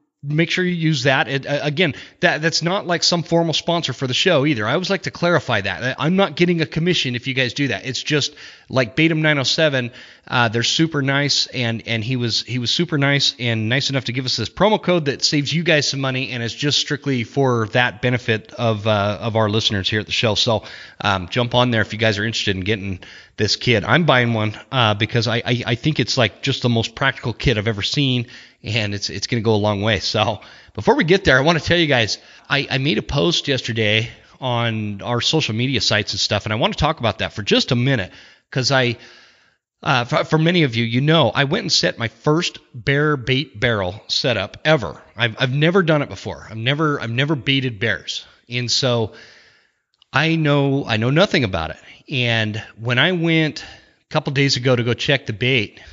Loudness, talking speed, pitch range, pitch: -18 LUFS, 230 wpm, 115-150 Hz, 125 Hz